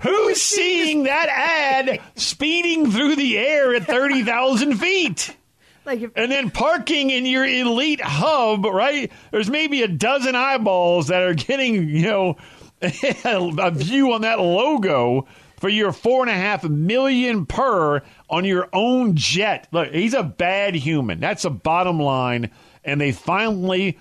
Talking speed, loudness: 145 wpm, -19 LUFS